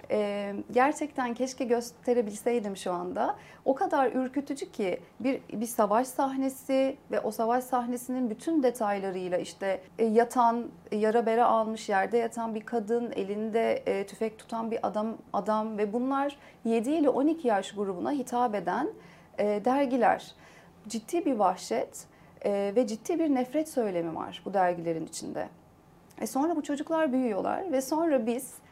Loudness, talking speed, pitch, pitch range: -29 LUFS, 145 wpm, 240 Hz, 215-270 Hz